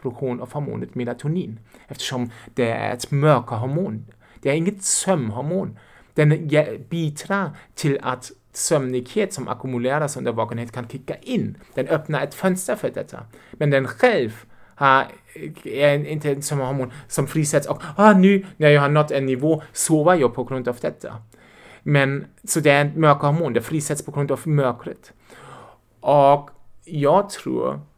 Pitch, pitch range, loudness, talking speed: 145 Hz, 125-155 Hz, -21 LUFS, 150 wpm